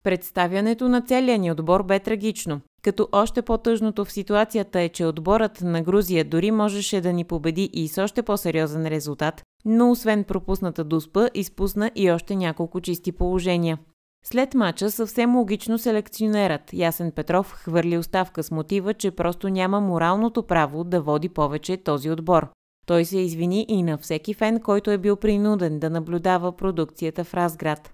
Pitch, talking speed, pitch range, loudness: 185 Hz, 160 wpm, 165-210 Hz, -23 LUFS